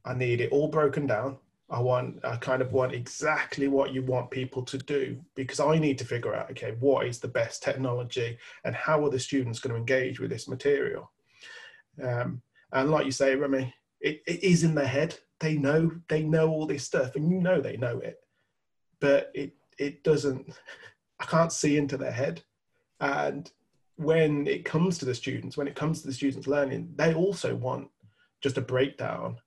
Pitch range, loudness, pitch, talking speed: 130-155 Hz, -28 LUFS, 140 Hz, 200 wpm